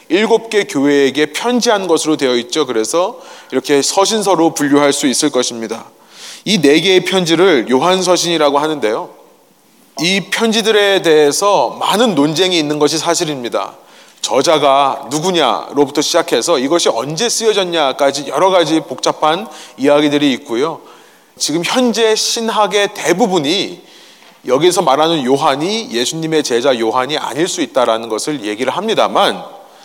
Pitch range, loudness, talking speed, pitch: 140-195 Hz, -13 LUFS, 325 characters per minute, 155 Hz